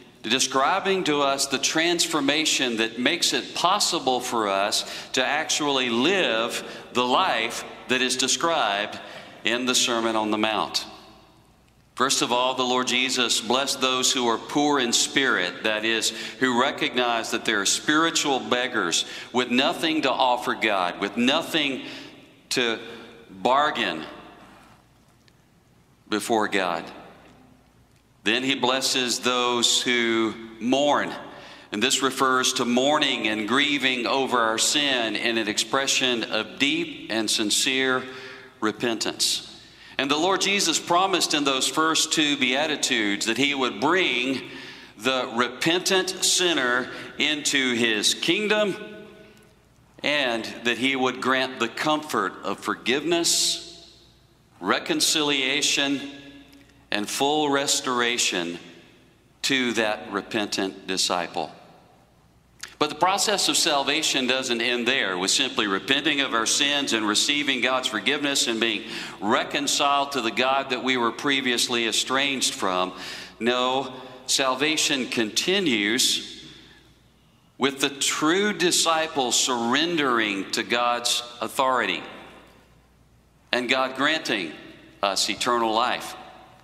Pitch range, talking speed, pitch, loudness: 115-140 Hz, 115 wpm, 130 Hz, -22 LUFS